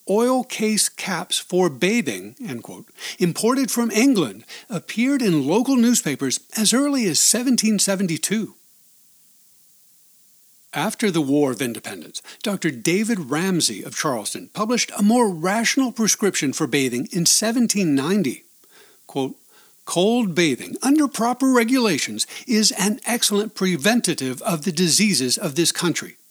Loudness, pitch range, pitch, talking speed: -20 LUFS, 170-235 Hz, 205 Hz, 120 wpm